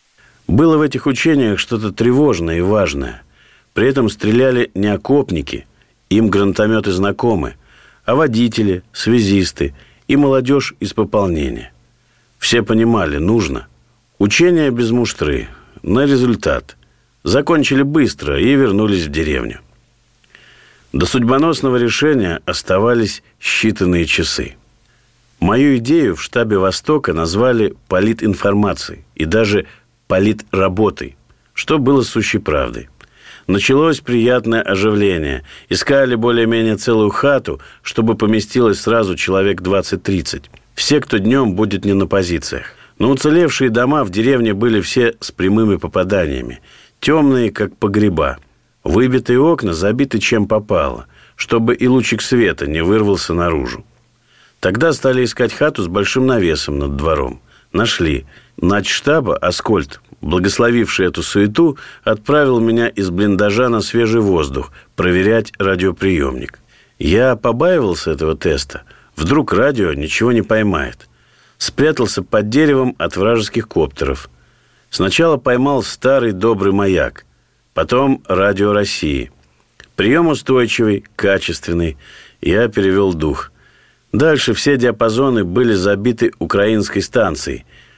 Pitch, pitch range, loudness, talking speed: 110 Hz, 95-125 Hz, -15 LUFS, 110 wpm